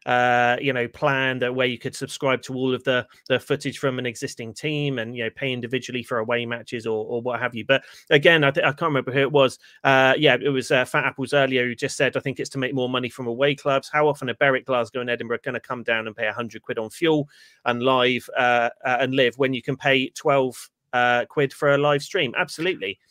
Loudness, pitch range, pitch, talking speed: -22 LUFS, 120-140 Hz, 130 Hz, 255 wpm